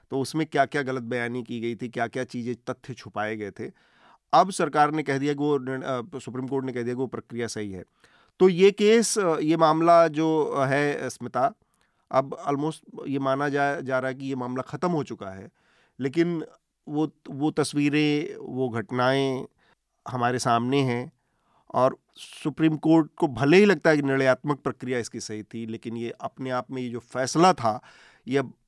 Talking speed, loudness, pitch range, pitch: 185 wpm, -25 LUFS, 125-150 Hz, 135 Hz